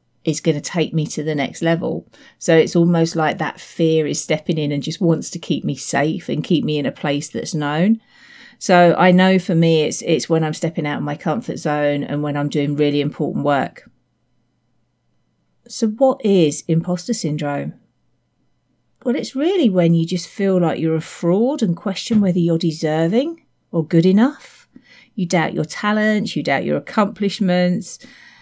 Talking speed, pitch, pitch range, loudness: 185 wpm, 170 Hz, 155-210 Hz, -18 LUFS